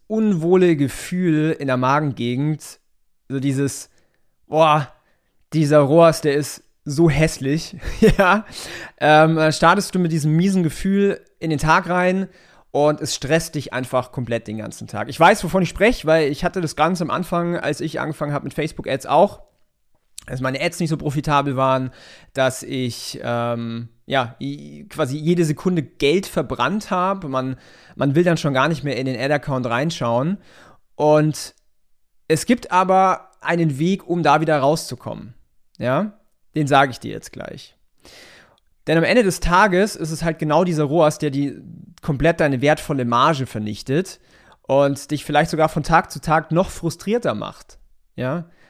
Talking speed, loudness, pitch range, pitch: 160 wpm, -19 LUFS, 140-175 Hz, 155 Hz